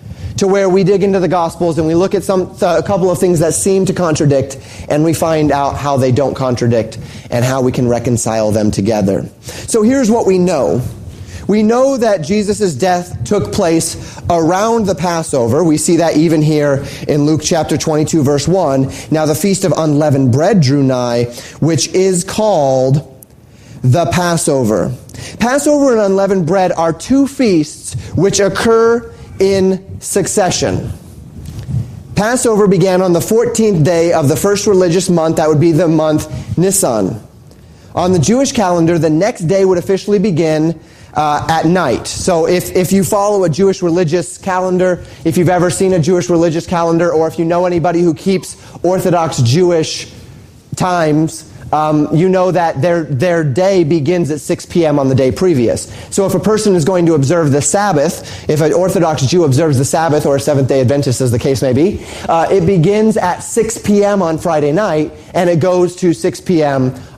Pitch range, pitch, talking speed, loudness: 140-185 Hz, 165 Hz, 180 wpm, -13 LUFS